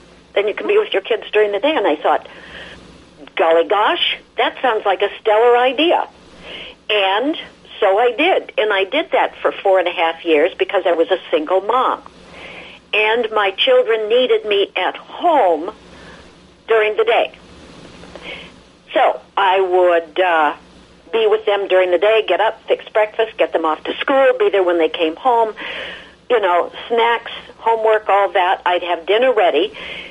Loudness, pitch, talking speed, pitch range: -16 LUFS, 215 Hz, 170 wpm, 185-255 Hz